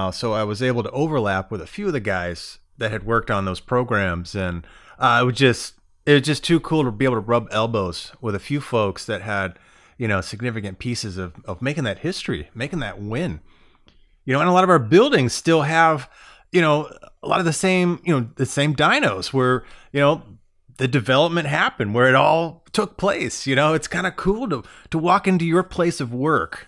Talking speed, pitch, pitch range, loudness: 220 wpm, 130 Hz, 110-160 Hz, -20 LUFS